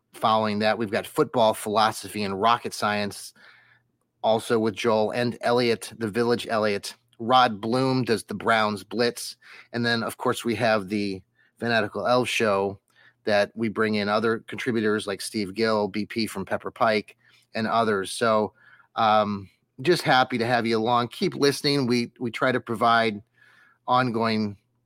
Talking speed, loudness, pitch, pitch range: 155 wpm, -24 LUFS, 115 Hz, 105-120 Hz